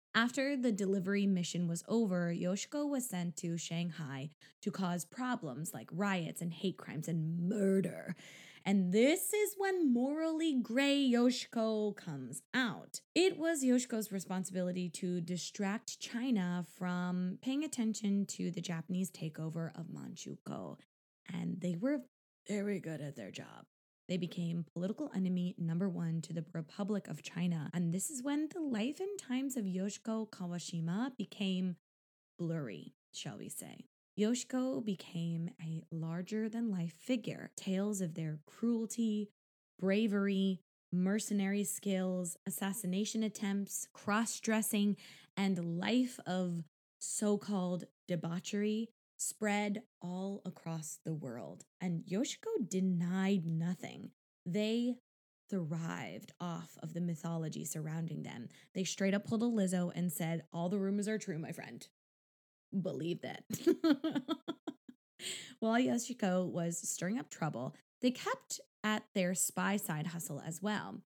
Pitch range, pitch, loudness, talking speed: 175-225 Hz, 190 Hz, -37 LUFS, 130 wpm